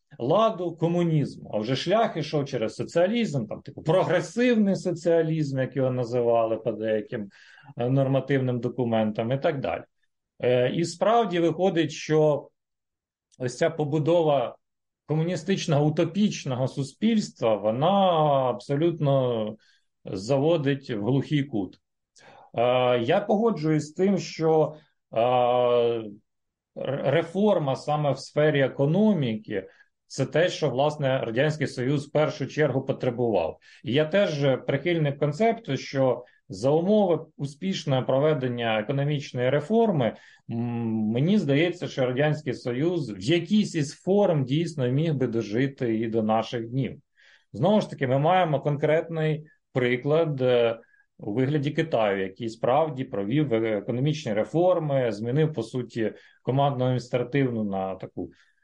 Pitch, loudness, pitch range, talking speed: 140 Hz, -25 LUFS, 125-165 Hz, 115 wpm